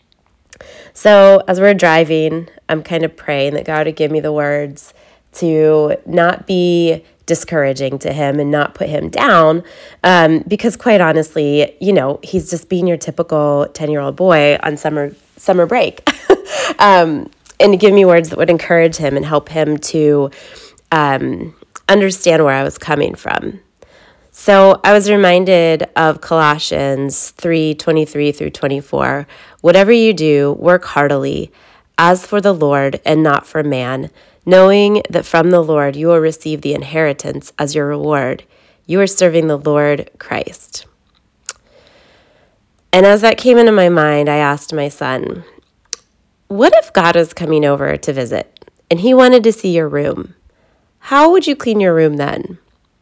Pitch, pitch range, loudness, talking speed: 160 Hz, 145-185 Hz, -12 LUFS, 160 wpm